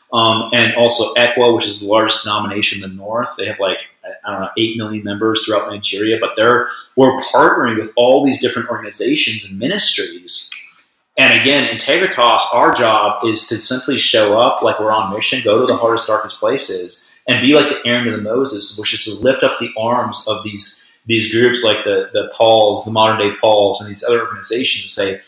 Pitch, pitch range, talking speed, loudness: 110 Hz, 105-120 Hz, 205 wpm, -14 LUFS